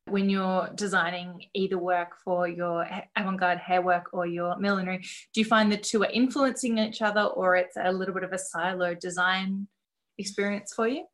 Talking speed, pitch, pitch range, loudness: 190 wpm, 190 Hz, 180-210 Hz, -27 LUFS